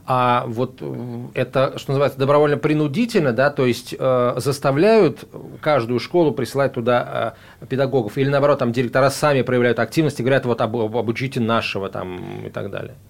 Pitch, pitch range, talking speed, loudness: 130 Hz, 120-140 Hz, 160 wpm, -19 LUFS